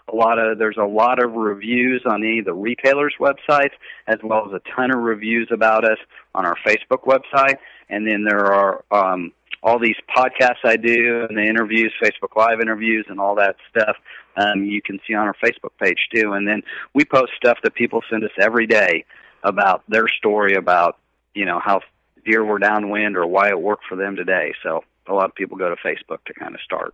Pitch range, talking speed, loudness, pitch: 105-120 Hz, 215 wpm, -18 LUFS, 110 Hz